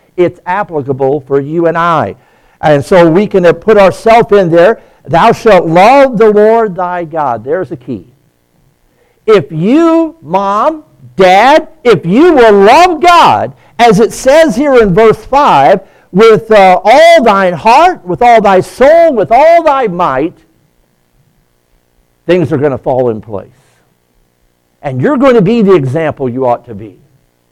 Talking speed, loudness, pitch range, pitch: 155 wpm, -7 LUFS, 135-230 Hz, 180 Hz